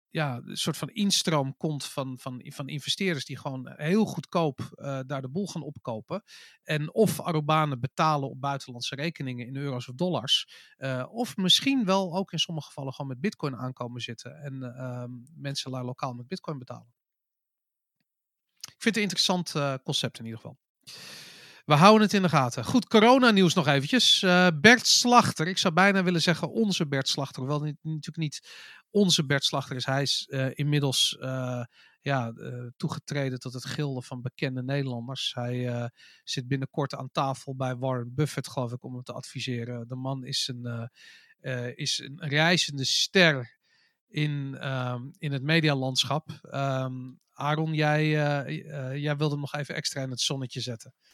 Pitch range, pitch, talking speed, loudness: 130-165 Hz, 140 Hz, 175 wpm, -26 LUFS